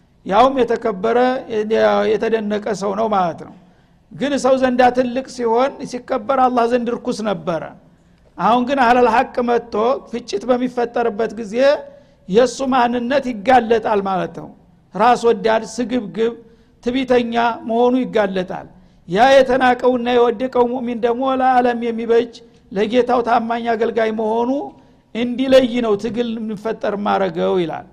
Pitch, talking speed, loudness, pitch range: 235 Hz, 115 wpm, -17 LUFS, 220-250 Hz